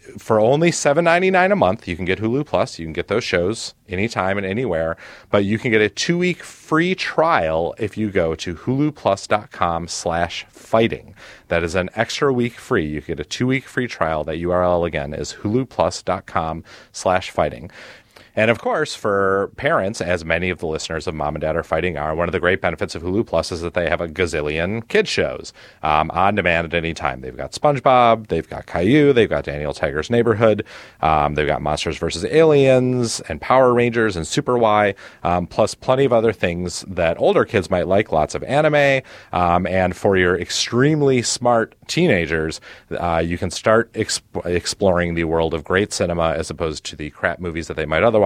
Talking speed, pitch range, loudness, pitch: 195 wpm, 85-125 Hz, -19 LUFS, 95 Hz